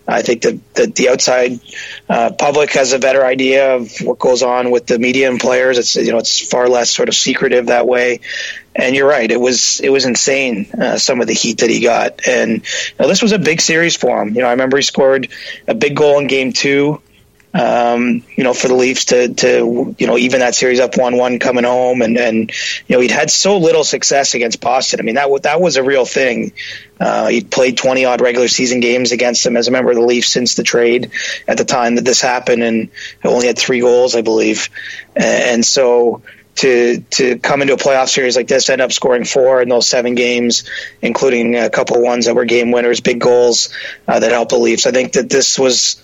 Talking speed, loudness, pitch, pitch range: 235 wpm, -12 LUFS, 125 Hz, 120-130 Hz